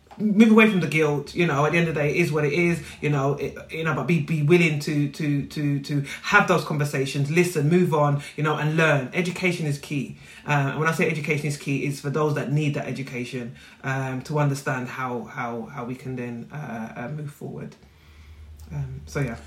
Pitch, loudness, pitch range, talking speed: 145 Hz, -23 LUFS, 130-160 Hz, 230 wpm